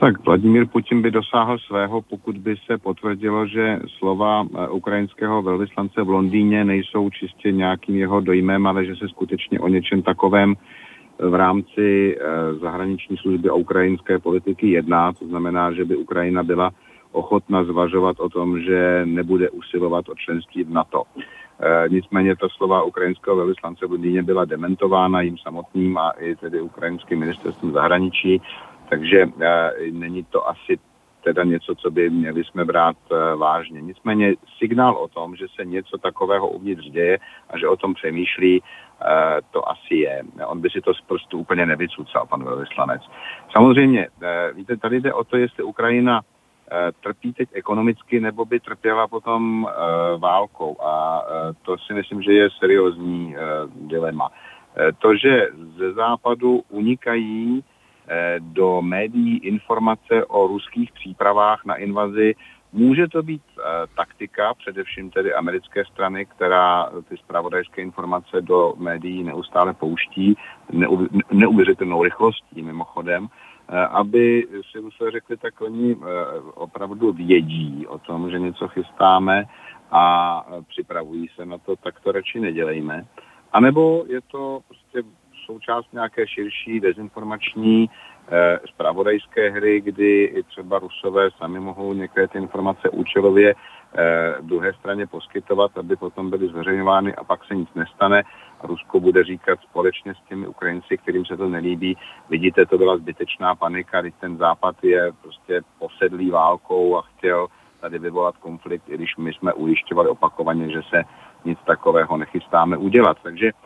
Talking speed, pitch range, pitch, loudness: 145 wpm, 90-110 Hz, 95 Hz, -20 LUFS